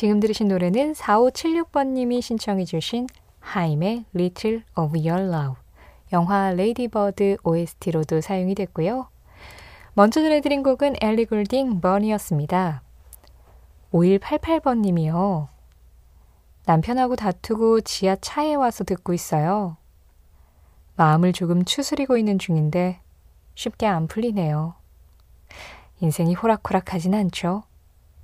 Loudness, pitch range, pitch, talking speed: -22 LUFS, 160-225 Hz, 190 Hz, 265 characters per minute